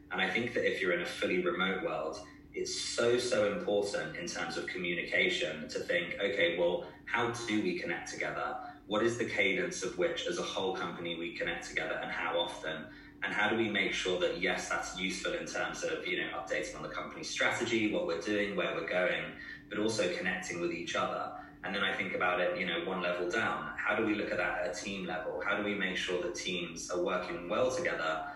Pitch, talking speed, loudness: 105 Hz, 230 wpm, -33 LUFS